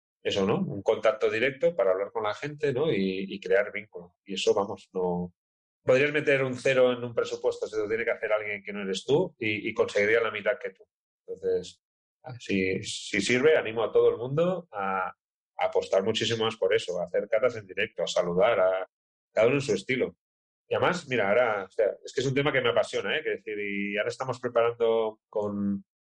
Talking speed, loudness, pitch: 220 wpm, -27 LUFS, 170 Hz